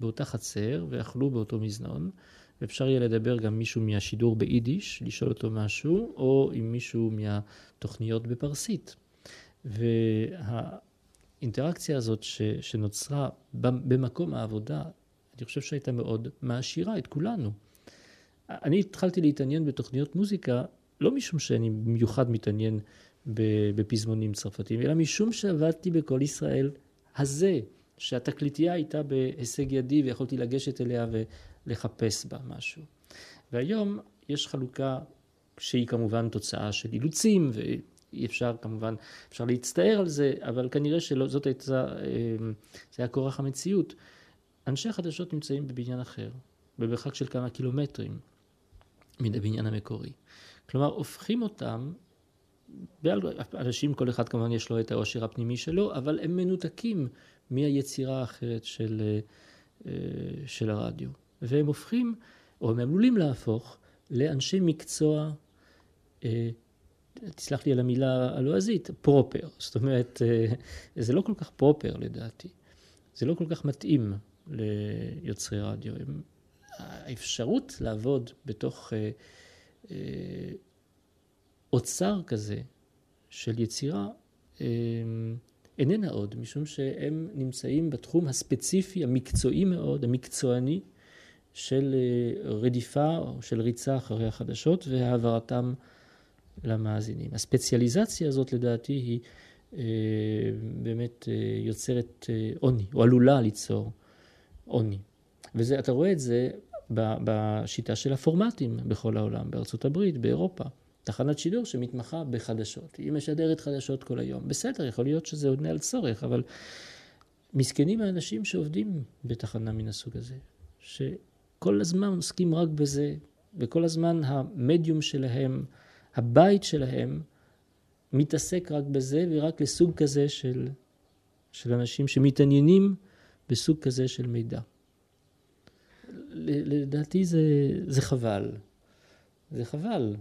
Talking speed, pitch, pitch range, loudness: 105 wpm, 125 Hz, 110-145 Hz, -29 LUFS